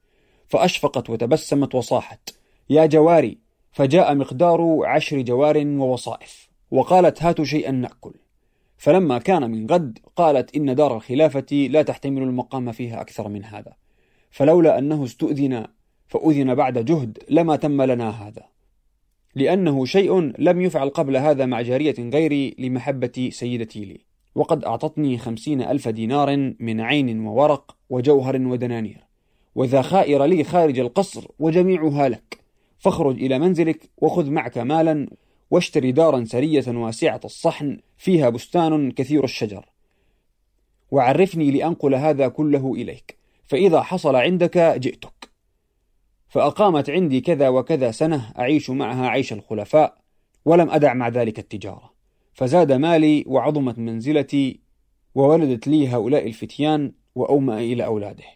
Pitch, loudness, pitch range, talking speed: 140 Hz, -20 LUFS, 125-155 Hz, 120 wpm